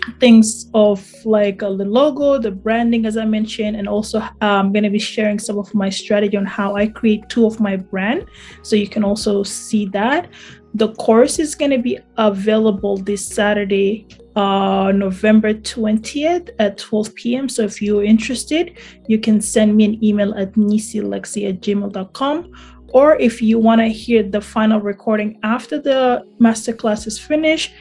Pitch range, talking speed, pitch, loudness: 205-230 Hz, 175 wpm, 215 Hz, -17 LUFS